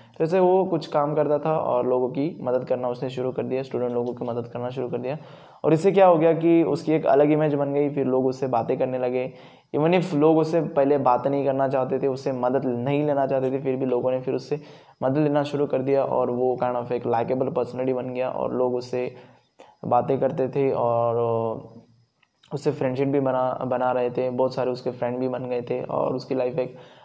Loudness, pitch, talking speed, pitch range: -23 LUFS, 130 Hz, 230 wpm, 125-145 Hz